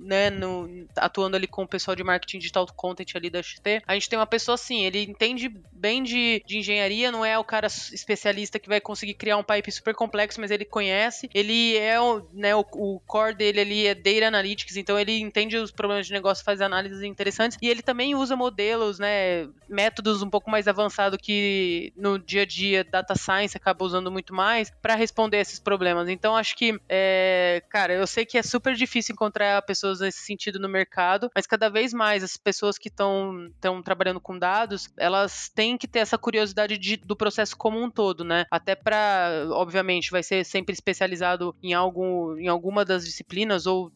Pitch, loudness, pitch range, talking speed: 205 Hz, -24 LUFS, 190-220 Hz, 200 wpm